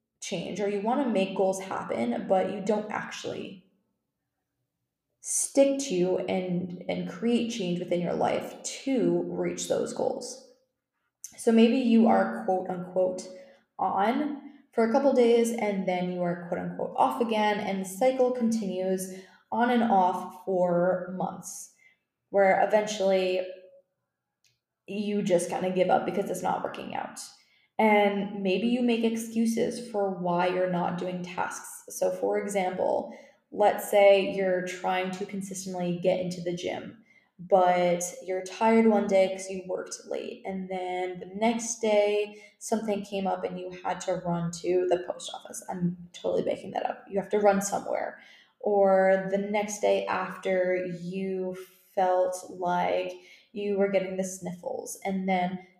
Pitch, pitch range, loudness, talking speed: 190 Hz, 180-215 Hz, -28 LUFS, 155 wpm